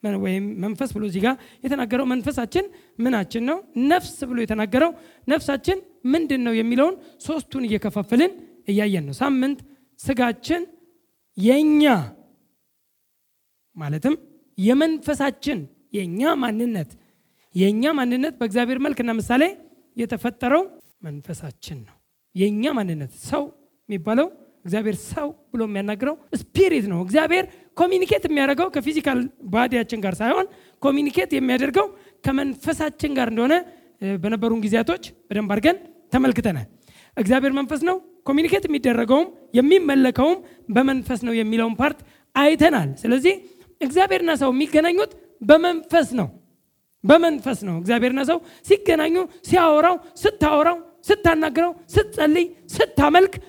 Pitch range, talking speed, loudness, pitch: 230-330 Hz, 100 wpm, -21 LUFS, 280 Hz